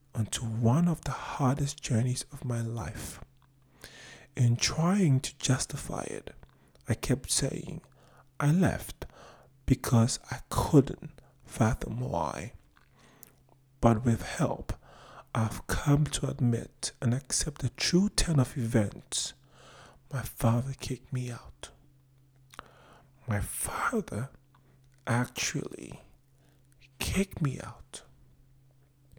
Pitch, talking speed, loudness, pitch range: 130 Hz, 100 wpm, -30 LUFS, 120-140 Hz